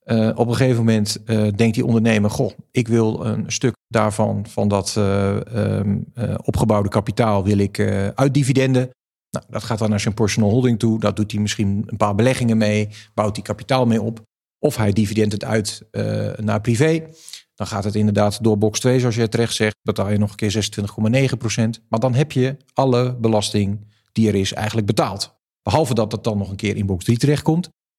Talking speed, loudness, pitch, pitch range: 205 wpm, -19 LUFS, 110 Hz, 105-120 Hz